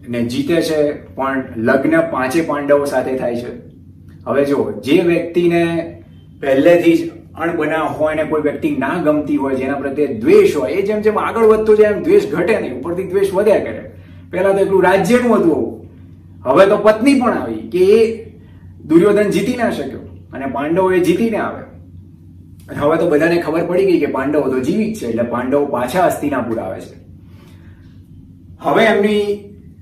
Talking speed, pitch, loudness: 160 wpm, 150 Hz, -15 LUFS